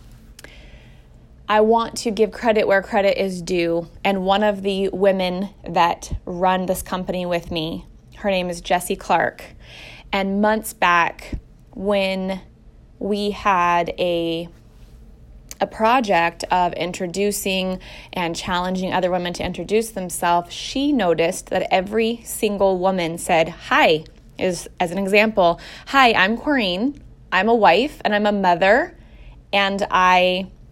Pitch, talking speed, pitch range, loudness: 185 Hz, 130 wpm, 175-205 Hz, -20 LUFS